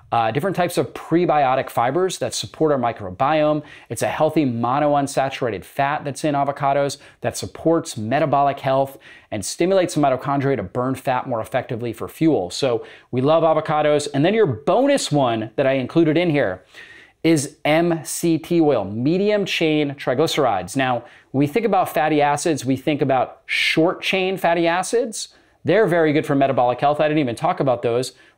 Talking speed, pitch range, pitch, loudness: 165 wpm, 135-165 Hz, 145 Hz, -20 LUFS